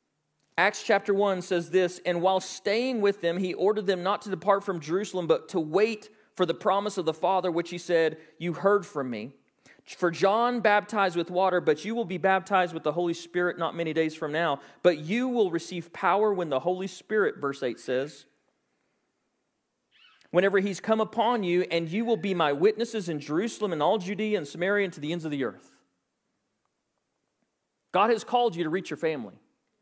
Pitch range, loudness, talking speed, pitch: 170-210 Hz, -27 LUFS, 195 wpm, 185 Hz